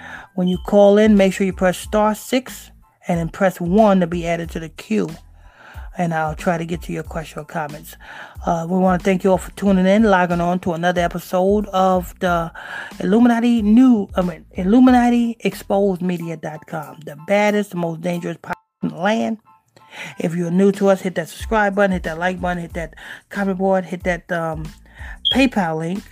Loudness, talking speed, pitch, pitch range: -18 LUFS, 195 wpm, 185 Hz, 170-205 Hz